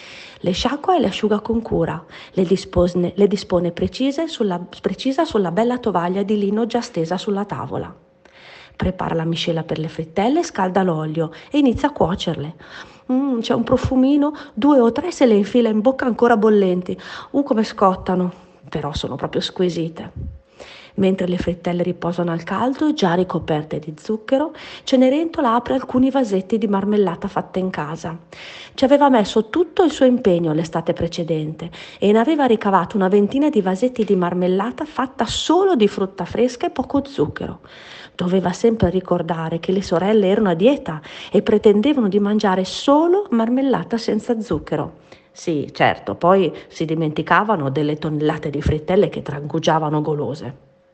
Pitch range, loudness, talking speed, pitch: 175-245 Hz, -19 LUFS, 155 wpm, 200 Hz